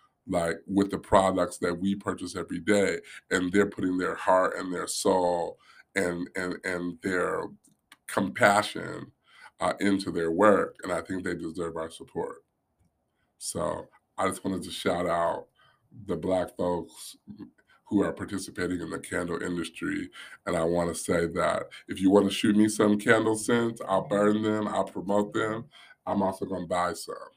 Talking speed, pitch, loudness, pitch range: 170 wpm, 95 Hz, -28 LUFS, 85-105 Hz